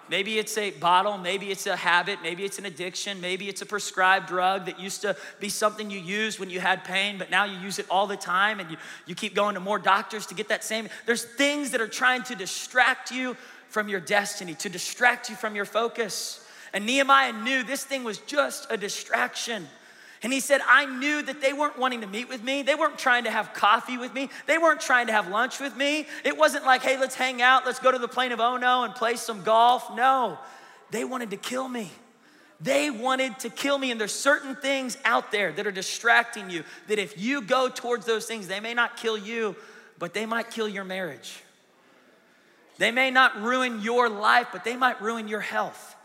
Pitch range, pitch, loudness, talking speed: 200-255 Hz, 225 Hz, -25 LUFS, 225 wpm